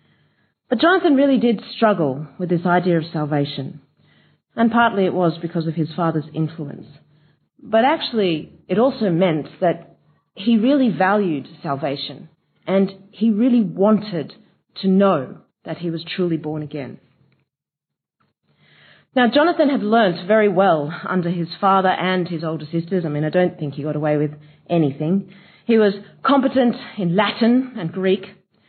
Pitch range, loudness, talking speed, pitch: 160-220 Hz, -19 LUFS, 150 wpm, 185 Hz